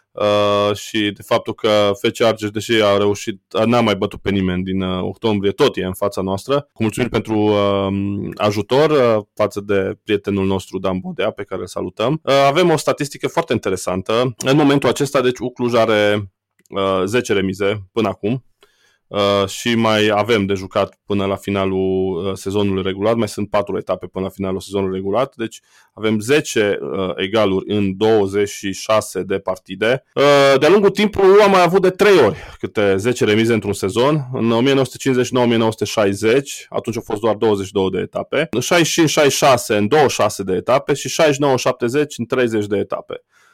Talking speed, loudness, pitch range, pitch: 165 wpm, -17 LUFS, 100-125 Hz, 105 Hz